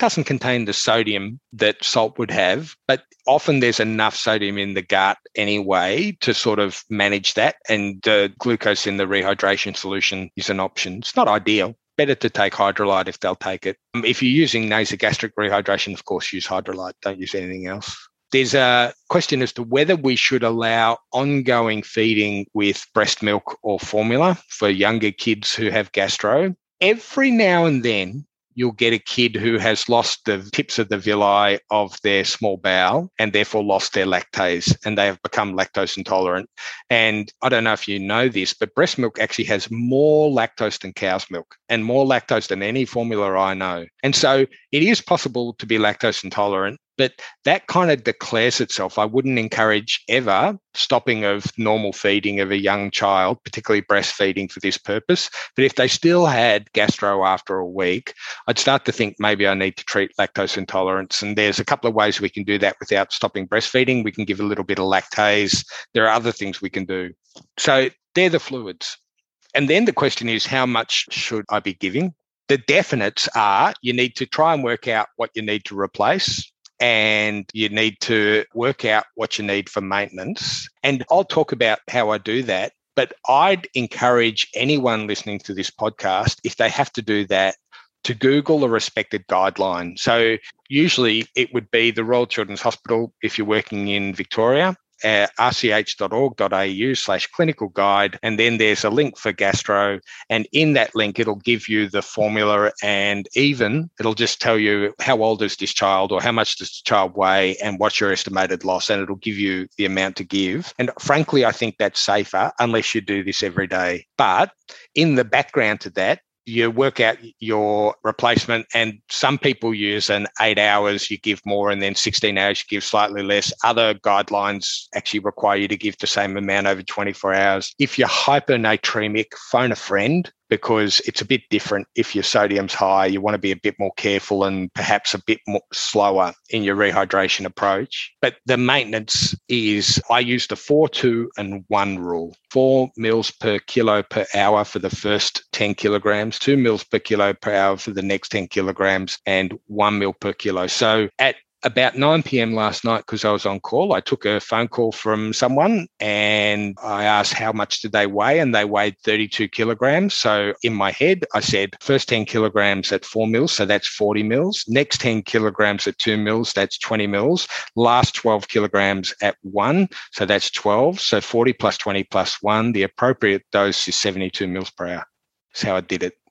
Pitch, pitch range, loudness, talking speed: 105 Hz, 100-120 Hz, -19 LUFS, 190 wpm